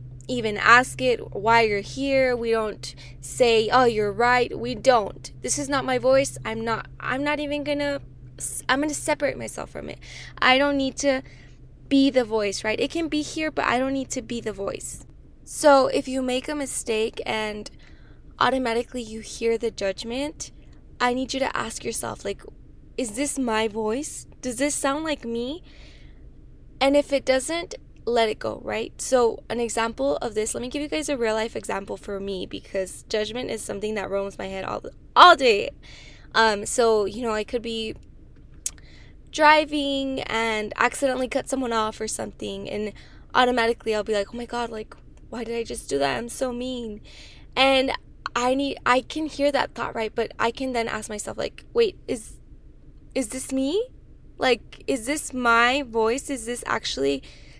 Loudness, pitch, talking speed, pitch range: -24 LUFS, 245 Hz, 185 wpm, 220-275 Hz